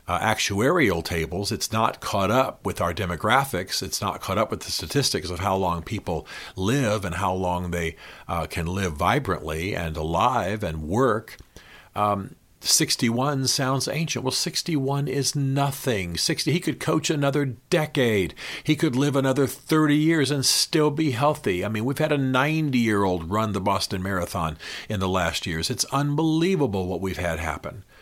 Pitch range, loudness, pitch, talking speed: 90-140 Hz, -24 LUFS, 110 Hz, 165 wpm